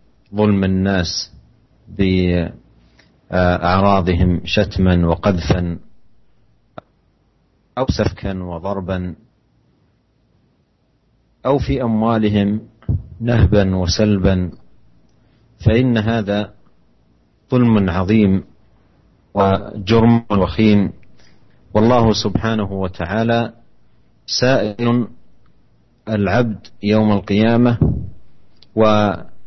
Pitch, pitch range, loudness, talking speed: 100 Hz, 90-110 Hz, -17 LUFS, 55 wpm